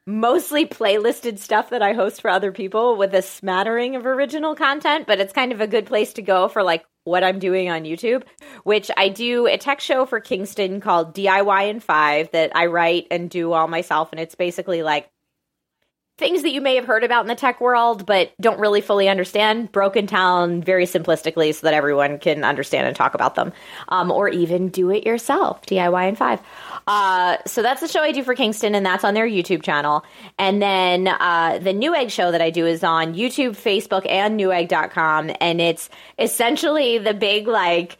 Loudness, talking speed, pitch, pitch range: -19 LUFS, 205 wpm, 195 Hz, 175-235 Hz